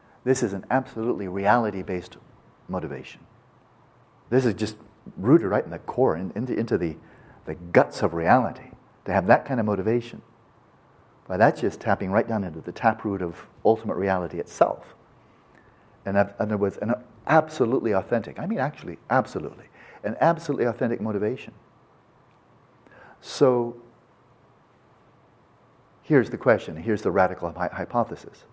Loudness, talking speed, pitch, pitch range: -25 LUFS, 135 wpm, 115 Hz, 100-125 Hz